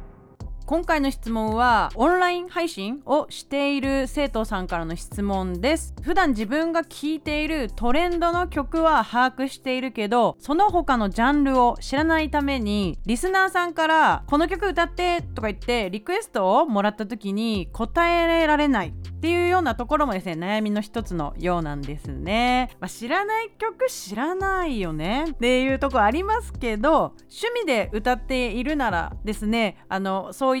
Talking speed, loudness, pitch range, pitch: 355 characters per minute, -23 LUFS, 220-325 Hz, 265 Hz